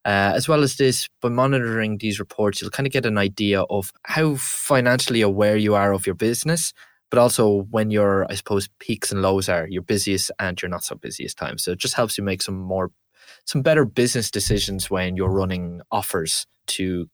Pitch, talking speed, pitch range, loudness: 105 Hz, 205 wpm, 95-125 Hz, -21 LUFS